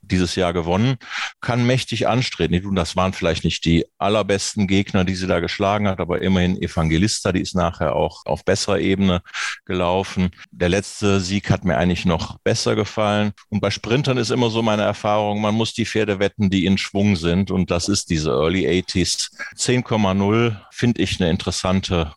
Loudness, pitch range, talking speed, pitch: -20 LUFS, 90-105 Hz, 180 wpm, 100 Hz